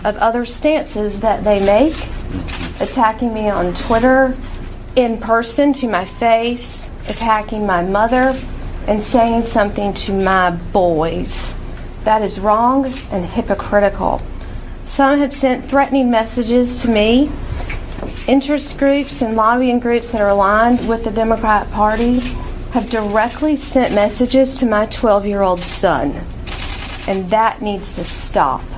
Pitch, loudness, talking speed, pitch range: 230 Hz, -16 LUFS, 130 wpm, 210-250 Hz